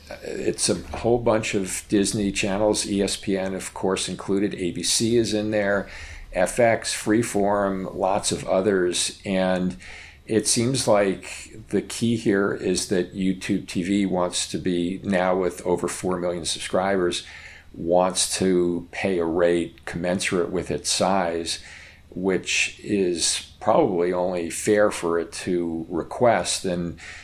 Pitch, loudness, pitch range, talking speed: 95 Hz, -23 LUFS, 85-100 Hz, 130 wpm